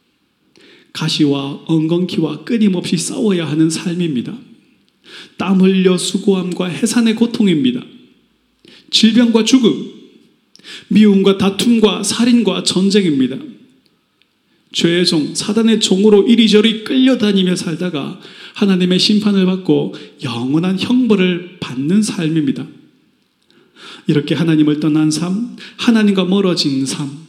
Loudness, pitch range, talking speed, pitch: -14 LUFS, 170-220 Hz, 250 characters per minute, 195 Hz